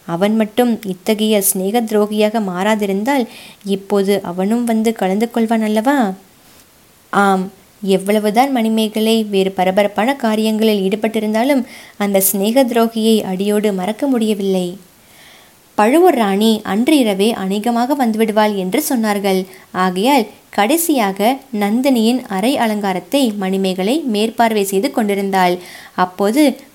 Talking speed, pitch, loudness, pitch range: 95 wpm, 215 Hz, -15 LUFS, 195-235 Hz